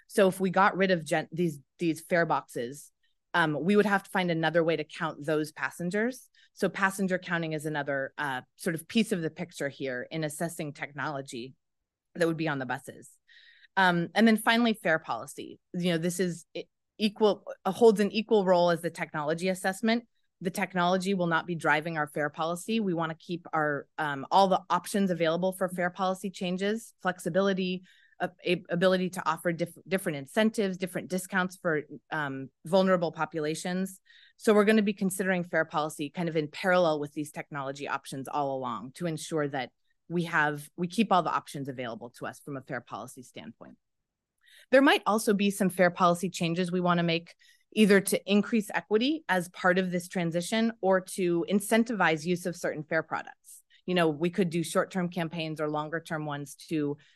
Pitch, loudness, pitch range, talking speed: 175 Hz, -29 LUFS, 155-190 Hz, 185 wpm